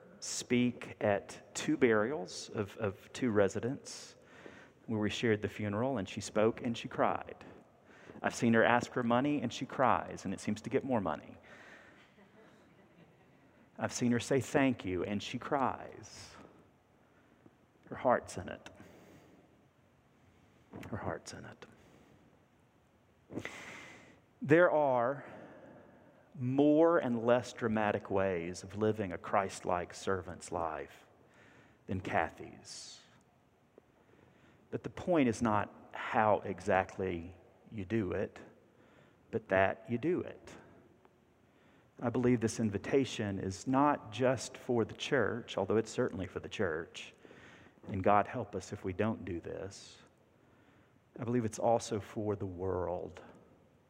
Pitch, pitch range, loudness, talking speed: 110 Hz, 100-125 Hz, -34 LUFS, 130 wpm